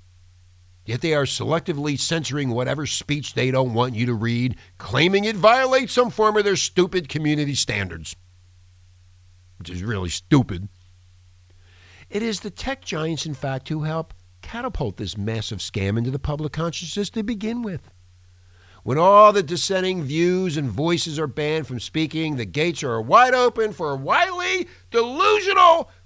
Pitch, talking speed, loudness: 145 Hz, 155 wpm, -21 LUFS